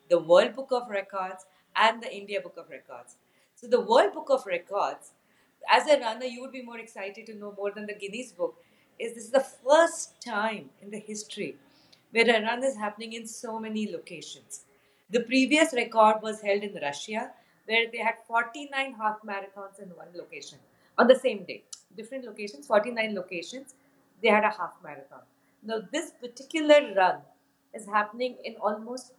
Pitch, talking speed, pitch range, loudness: 225 Hz, 180 wpm, 205-265 Hz, -27 LUFS